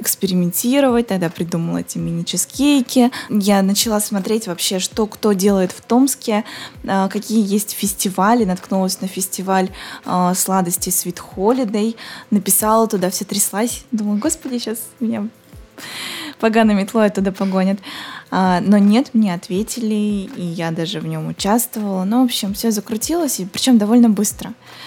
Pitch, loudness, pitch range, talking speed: 210 Hz, -17 LUFS, 190-230 Hz, 135 wpm